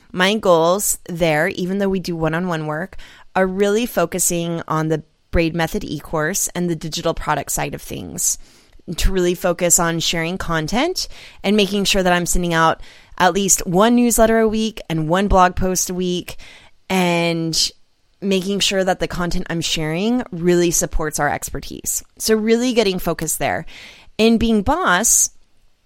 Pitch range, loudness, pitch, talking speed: 165-200 Hz, -18 LUFS, 180 Hz, 165 wpm